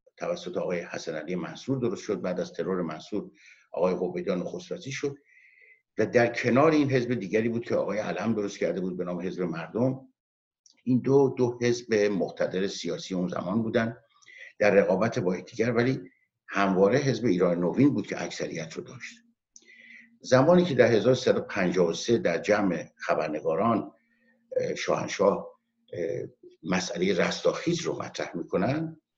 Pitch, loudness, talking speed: 130 Hz, -27 LUFS, 140 wpm